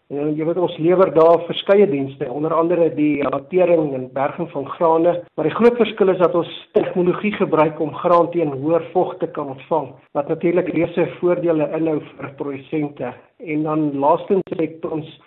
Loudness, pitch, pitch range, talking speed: -19 LUFS, 160 Hz, 150-175 Hz, 175 wpm